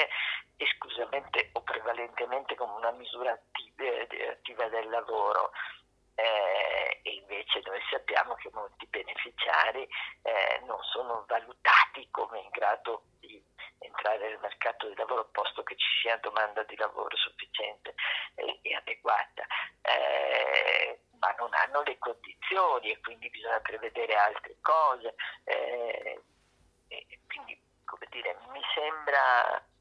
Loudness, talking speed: -30 LUFS, 120 wpm